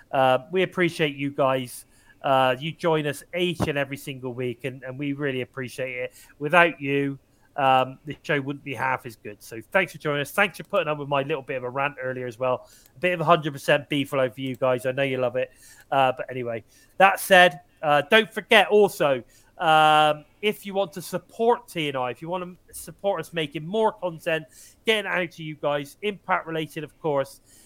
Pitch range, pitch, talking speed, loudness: 130-175 Hz, 145 Hz, 210 wpm, -24 LUFS